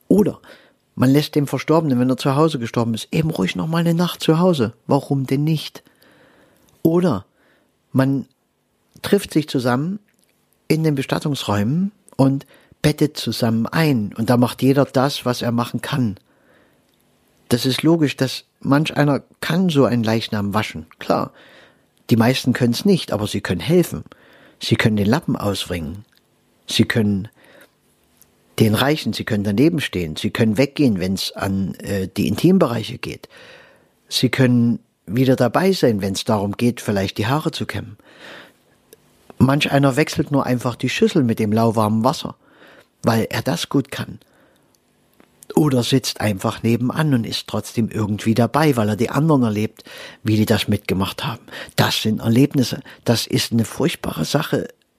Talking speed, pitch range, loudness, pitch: 155 wpm, 110-145 Hz, -19 LUFS, 125 Hz